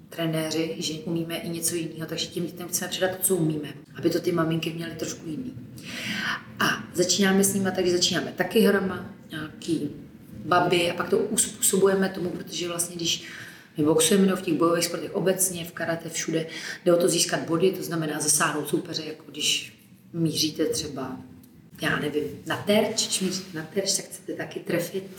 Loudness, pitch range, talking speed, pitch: -25 LUFS, 160-185 Hz, 175 wpm, 170 Hz